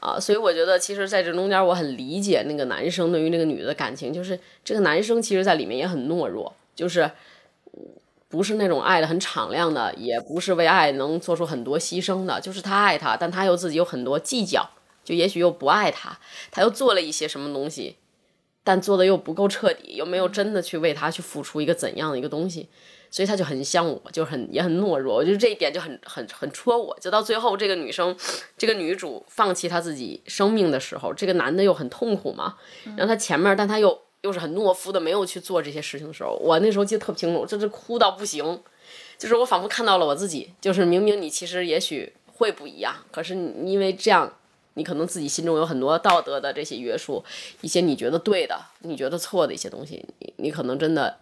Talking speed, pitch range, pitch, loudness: 350 characters per minute, 165-200 Hz, 180 Hz, -23 LUFS